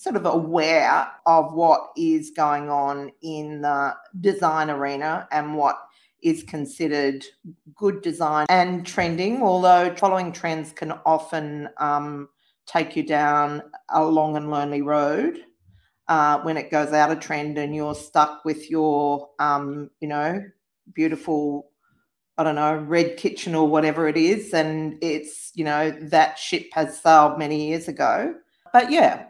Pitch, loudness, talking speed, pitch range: 155 Hz, -22 LUFS, 145 wpm, 150-170 Hz